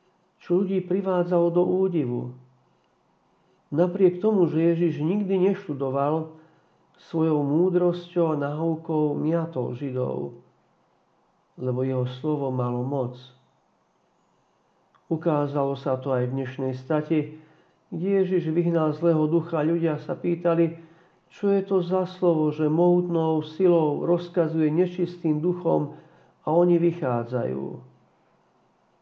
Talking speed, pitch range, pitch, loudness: 105 wpm, 145-175 Hz, 165 Hz, -24 LUFS